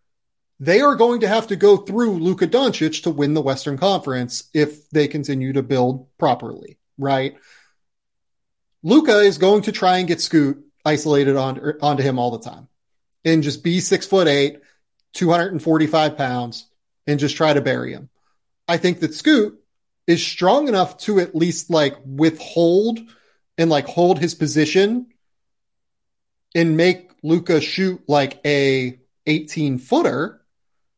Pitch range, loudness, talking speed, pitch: 140-180 Hz, -18 LUFS, 145 wpm, 155 Hz